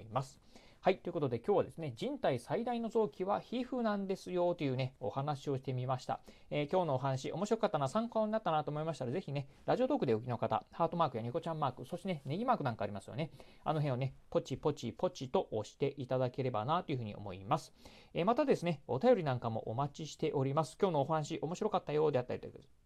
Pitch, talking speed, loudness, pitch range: 150 Hz, 510 characters per minute, -36 LUFS, 130-180 Hz